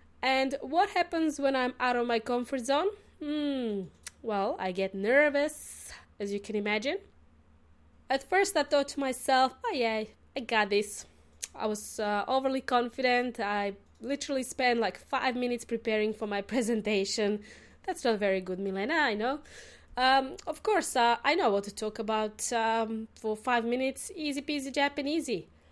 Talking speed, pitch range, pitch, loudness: 160 wpm, 215-275 Hz, 245 Hz, -30 LUFS